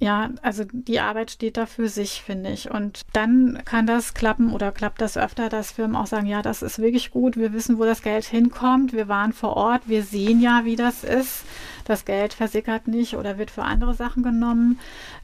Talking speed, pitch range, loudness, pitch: 215 wpm, 215-240 Hz, -22 LUFS, 225 Hz